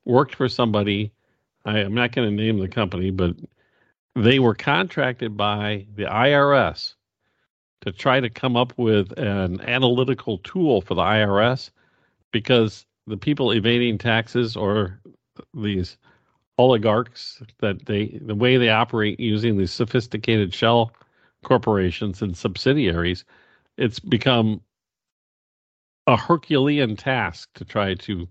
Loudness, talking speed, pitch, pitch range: -21 LUFS, 125 wpm, 110 Hz, 105-125 Hz